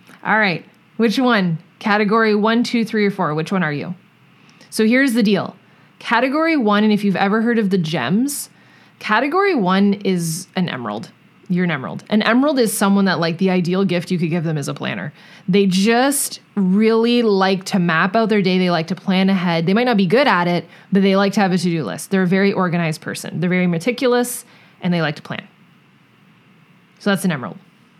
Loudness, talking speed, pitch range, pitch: -17 LUFS, 210 wpm, 180-220 Hz, 195 Hz